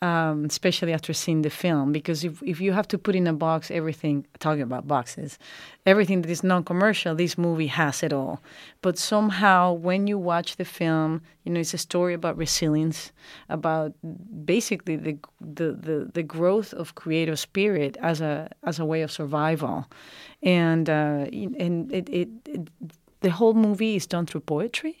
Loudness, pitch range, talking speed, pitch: -25 LUFS, 155-180 Hz, 175 wpm, 165 Hz